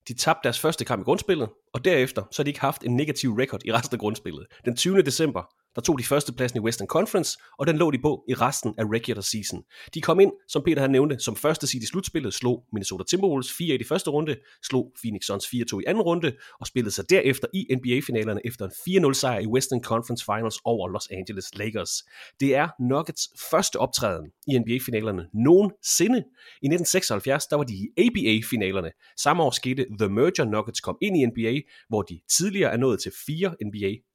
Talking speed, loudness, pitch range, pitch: 210 wpm, -25 LUFS, 110-145 Hz, 125 Hz